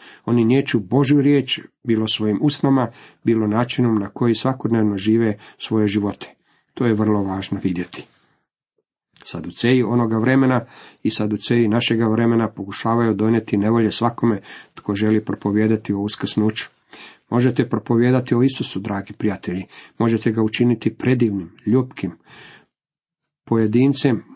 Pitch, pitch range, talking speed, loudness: 115 Hz, 105-125 Hz, 120 wpm, -19 LUFS